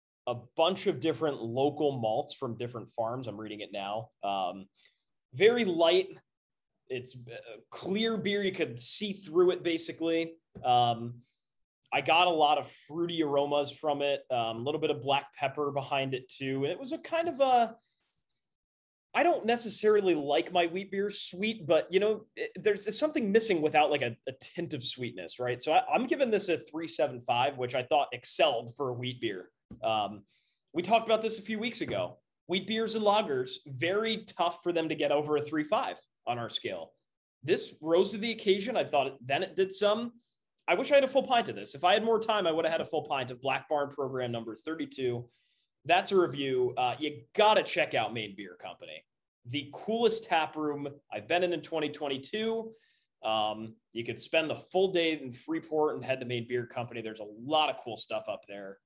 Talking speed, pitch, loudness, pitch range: 200 wpm, 155 Hz, -30 LUFS, 130-205 Hz